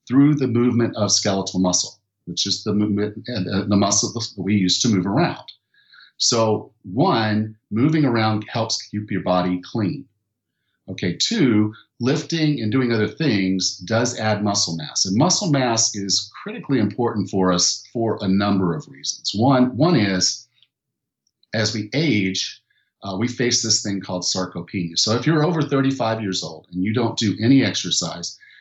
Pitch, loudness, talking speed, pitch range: 105 Hz, -20 LUFS, 165 wpm, 95-125 Hz